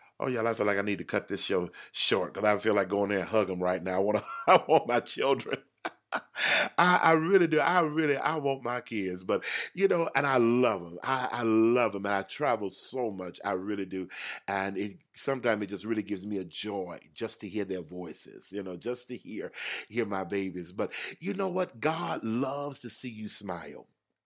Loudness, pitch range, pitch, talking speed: -29 LUFS, 95-130 Hz, 105 Hz, 230 wpm